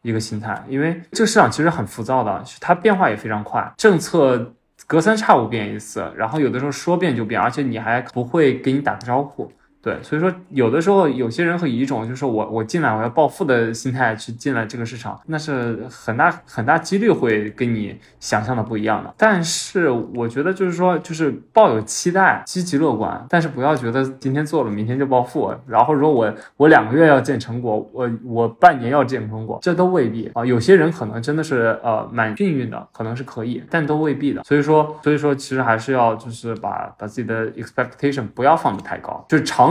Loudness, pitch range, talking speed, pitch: -19 LUFS, 115-155 Hz, 345 characters per minute, 130 Hz